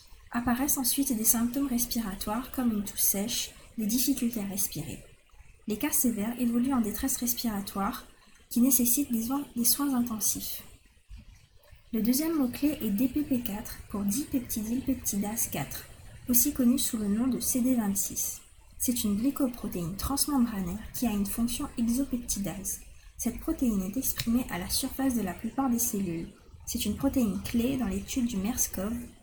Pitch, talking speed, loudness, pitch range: 235 Hz, 145 wpm, -29 LUFS, 210-260 Hz